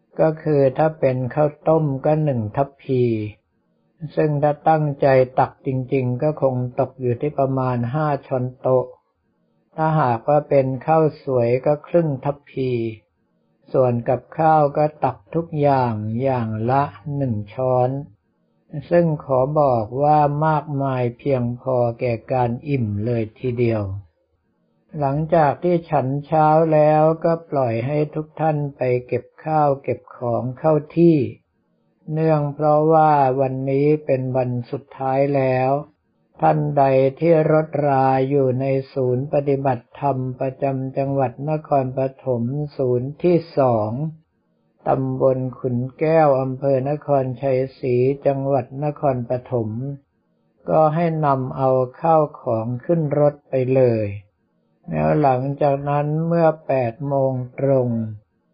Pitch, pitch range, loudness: 135 Hz, 125-150 Hz, -20 LUFS